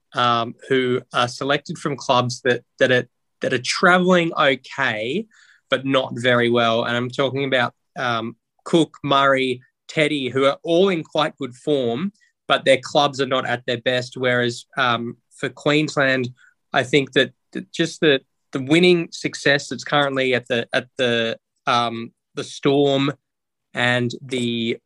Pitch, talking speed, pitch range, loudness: 130 Hz, 150 wpm, 120-145 Hz, -20 LUFS